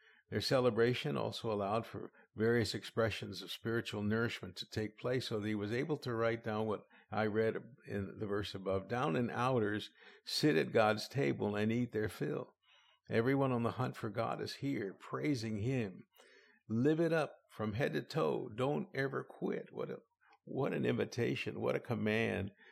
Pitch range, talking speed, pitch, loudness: 105-125 Hz, 175 wpm, 115 Hz, -37 LUFS